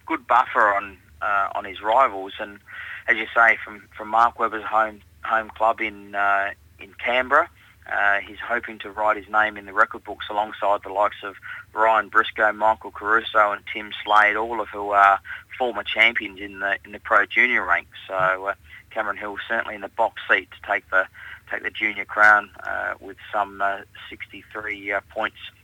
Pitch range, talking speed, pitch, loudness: 100-110 Hz, 185 wpm, 105 Hz, -21 LUFS